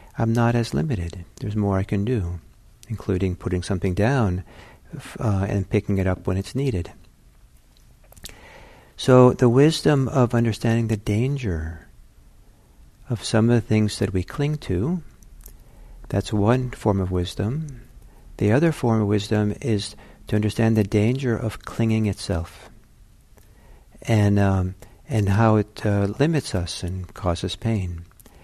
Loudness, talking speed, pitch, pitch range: -22 LUFS, 140 wpm, 105 Hz, 95-115 Hz